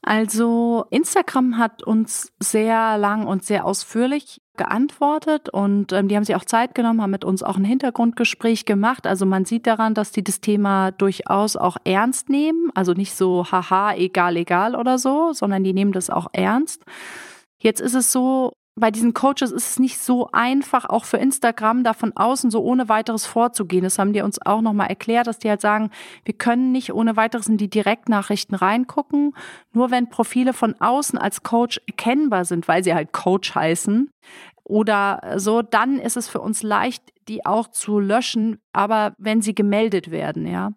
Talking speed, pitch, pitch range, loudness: 185 wpm, 220 Hz, 200-245 Hz, -20 LUFS